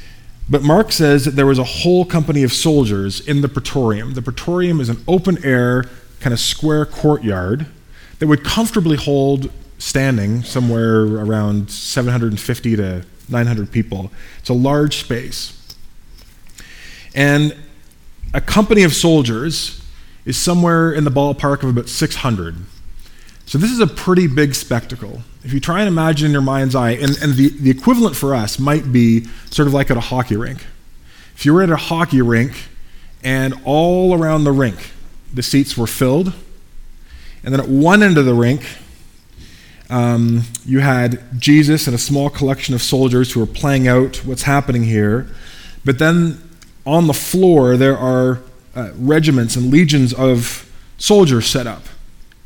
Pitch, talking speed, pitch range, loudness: 130 Hz, 160 wpm, 115-150 Hz, -15 LUFS